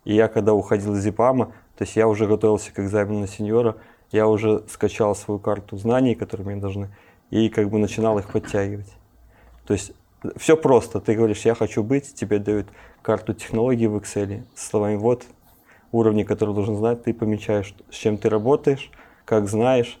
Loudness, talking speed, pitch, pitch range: -22 LUFS, 180 wpm, 110 Hz, 105-115 Hz